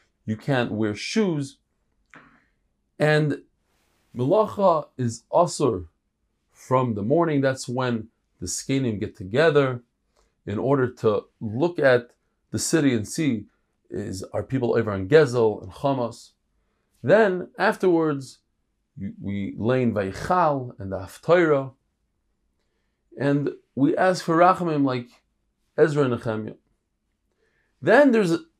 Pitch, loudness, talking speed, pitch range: 130 Hz, -23 LUFS, 110 wpm, 110-150 Hz